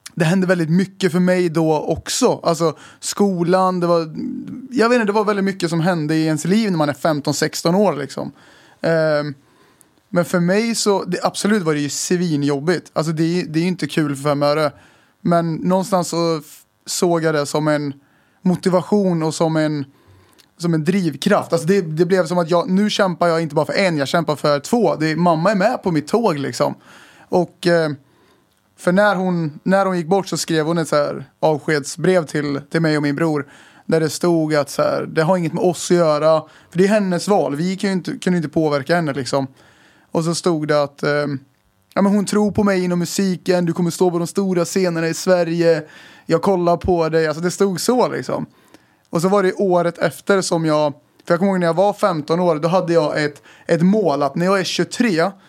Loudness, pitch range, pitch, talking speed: -18 LUFS, 155-190 Hz, 170 Hz, 215 wpm